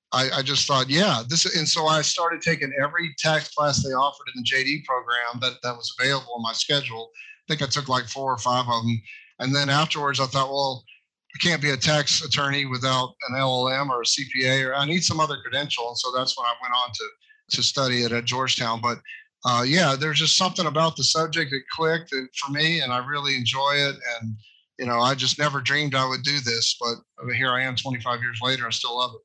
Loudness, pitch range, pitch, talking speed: -23 LUFS, 125-150 Hz, 135 Hz, 230 wpm